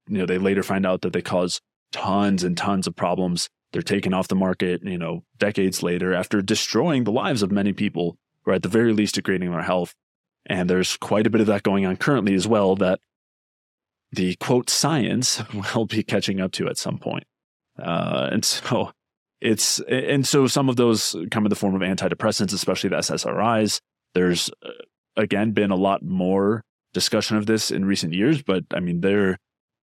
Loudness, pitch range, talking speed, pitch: -22 LUFS, 90-110 Hz, 195 wpm, 95 Hz